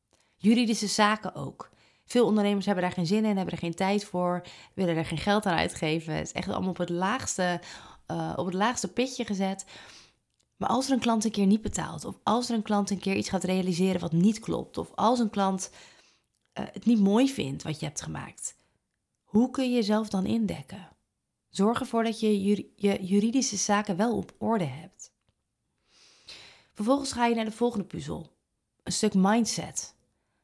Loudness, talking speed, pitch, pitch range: -28 LUFS, 190 wpm, 200 Hz, 180-225 Hz